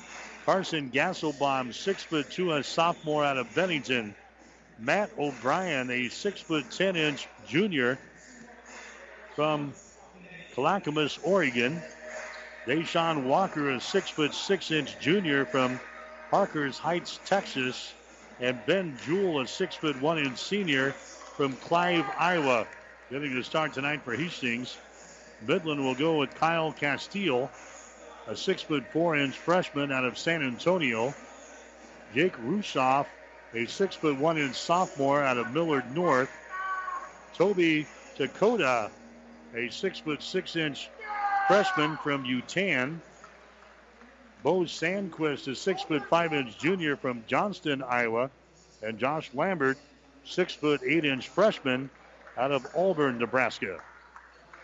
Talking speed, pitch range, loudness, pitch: 100 wpm, 130-175 Hz, -28 LUFS, 150 Hz